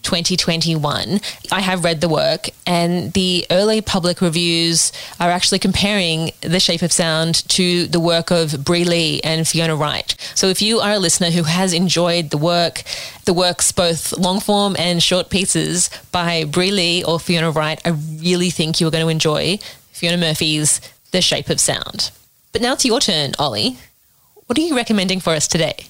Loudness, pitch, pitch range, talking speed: -16 LUFS, 175 Hz, 165-185 Hz, 185 wpm